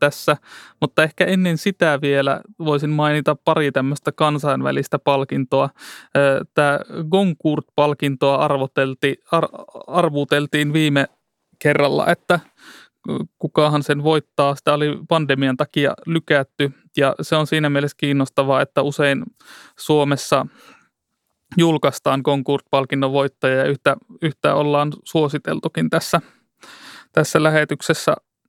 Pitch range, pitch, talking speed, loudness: 140-155 Hz, 145 Hz, 95 wpm, -19 LUFS